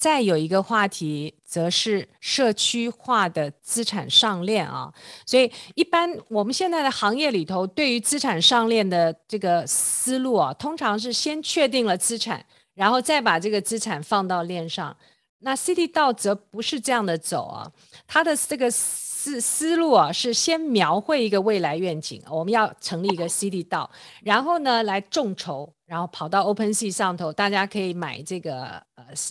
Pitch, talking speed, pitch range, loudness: 210 Hz, 265 characters per minute, 180-250 Hz, -22 LUFS